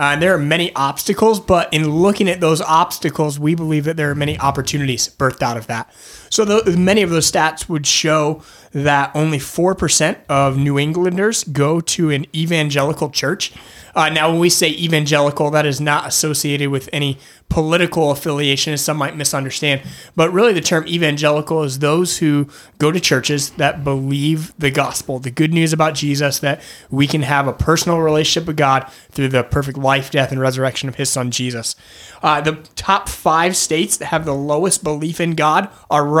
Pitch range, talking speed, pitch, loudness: 140-160 Hz, 190 wpm, 150 Hz, -16 LUFS